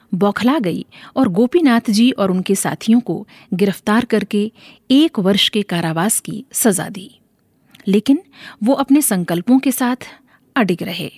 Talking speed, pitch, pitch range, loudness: 140 wpm, 215 Hz, 195-250 Hz, -16 LUFS